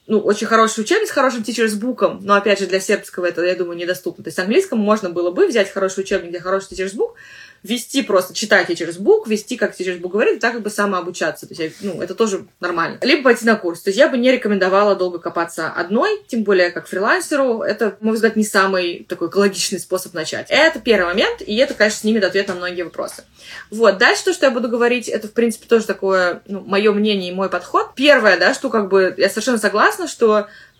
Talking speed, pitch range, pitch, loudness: 230 wpm, 185-230 Hz, 205 Hz, -17 LUFS